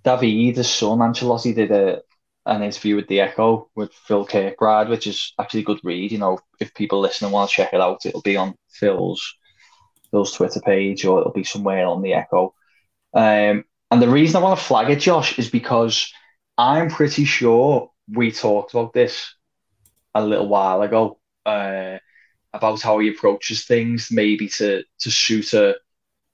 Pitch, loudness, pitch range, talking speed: 110 Hz, -19 LUFS, 100-120 Hz, 180 wpm